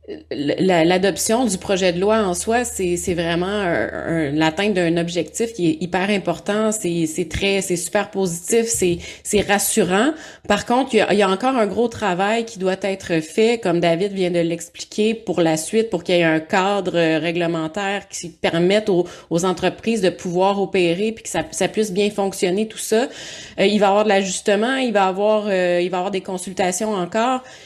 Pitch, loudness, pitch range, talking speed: 195 Hz, -19 LUFS, 175-210 Hz, 200 wpm